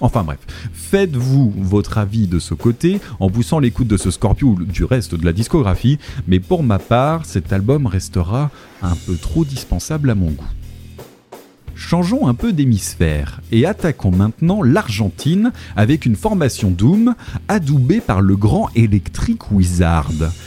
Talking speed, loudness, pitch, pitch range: 150 wpm, -16 LUFS, 110 Hz, 90-130 Hz